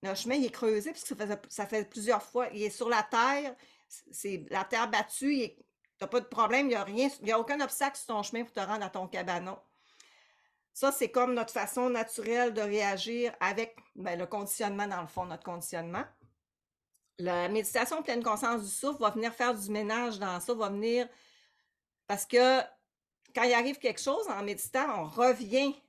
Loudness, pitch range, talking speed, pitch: -32 LUFS, 205-250 Hz, 190 wpm, 230 Hz